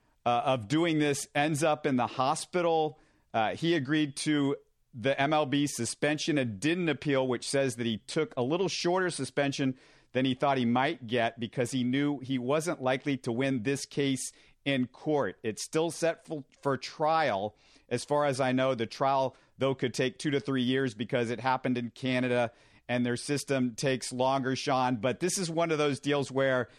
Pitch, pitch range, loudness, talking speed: 135 Hz, 125-150 Hz, -30 LUFS, 190 wpm